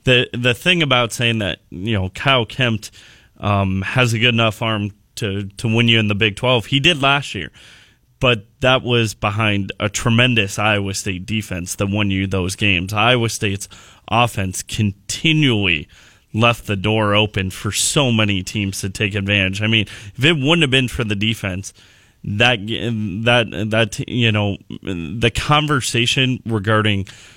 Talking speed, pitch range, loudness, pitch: 165 wpm, 100-120 Hz, -17 LUFS, 110 Hz